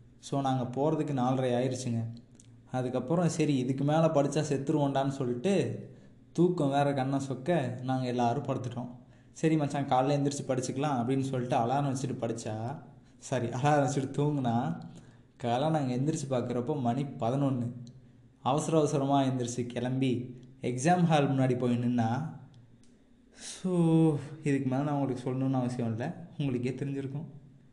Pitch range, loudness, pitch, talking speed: 125-145 Hz, -30 LUFS, 130 Hz, 125 wpm